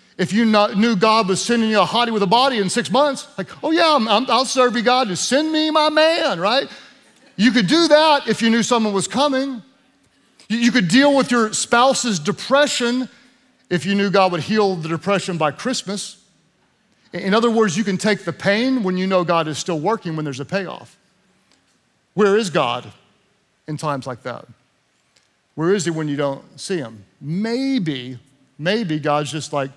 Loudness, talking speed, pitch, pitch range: -18 LUFS, 195 wpm, 210 Hz, 175-245 Hz